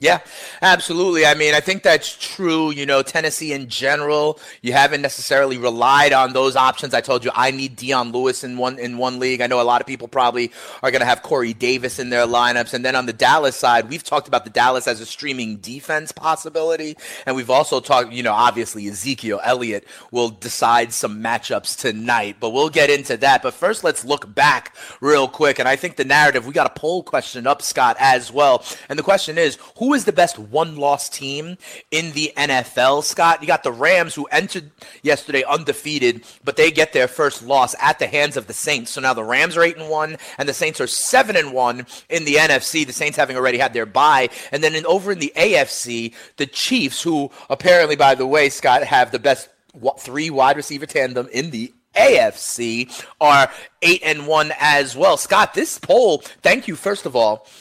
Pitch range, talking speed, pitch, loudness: 125-155 Hz, 210 wpm, 140 Hz, -17 LUFS